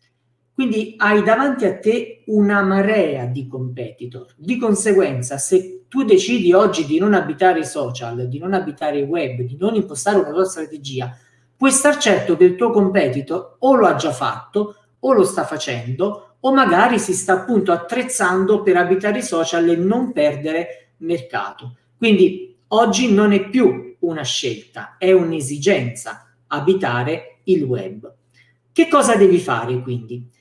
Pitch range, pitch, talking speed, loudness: 140-210 Hz, 185 Hz, 155 wpm, -17 LUFS